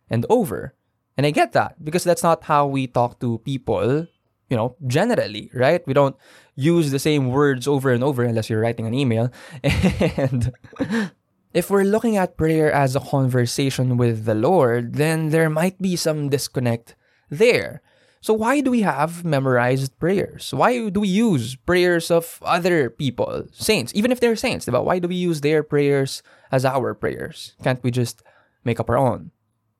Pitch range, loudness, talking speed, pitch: 125-175 Hz, -20 LUFS, 175 wpm, 145 Hz